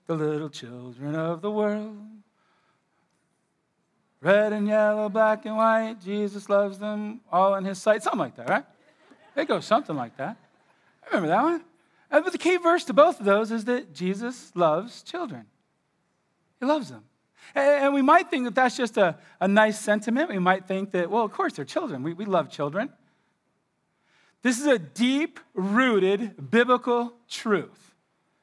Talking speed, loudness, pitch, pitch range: 165 wpm, -24 LUFS, 215 Hz, 190-250 Hz